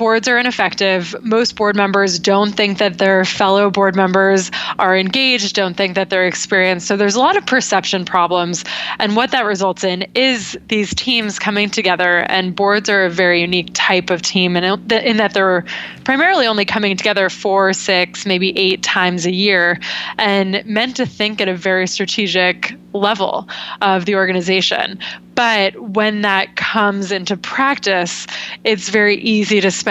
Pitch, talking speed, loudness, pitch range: 200 Hz, 165 wpm, -15 LUFS, 185-215 Hz